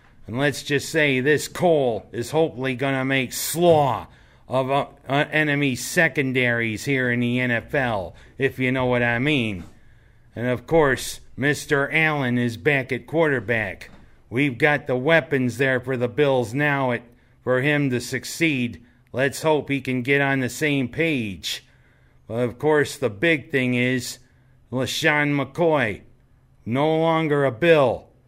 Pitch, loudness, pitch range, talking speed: 130 Hz, -22 LUFS, 120-145 Hz, 150 wpm